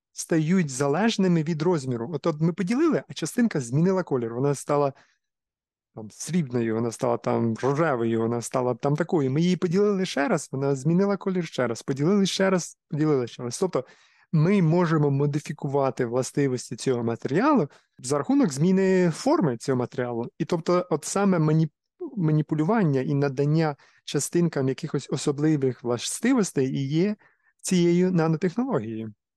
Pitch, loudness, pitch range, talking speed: 155 Hz, -25 LUFS, 130-180 Hz, 140 wpm